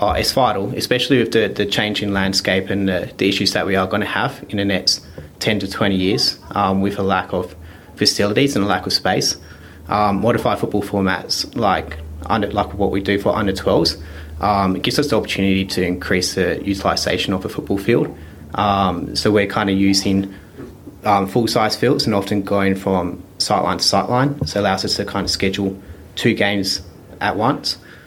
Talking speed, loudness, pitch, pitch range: 200 wpm, -18 LUFS, 100 Hz, 95-105 Hz